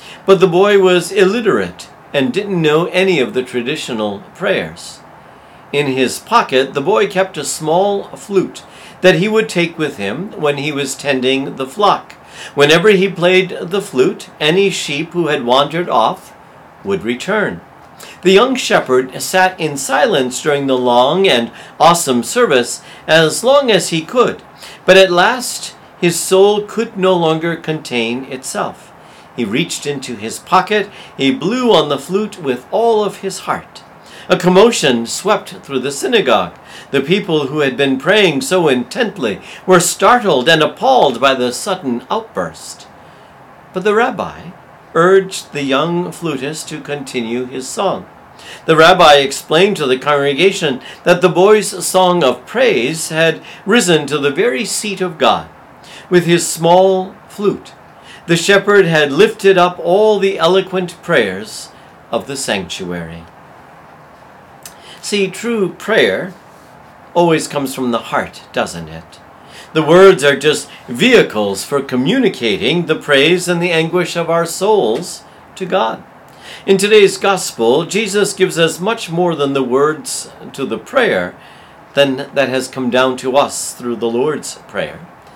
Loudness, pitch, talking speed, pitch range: -14 LUFS, 170 Hz, 150 wpm, 140-190 Hz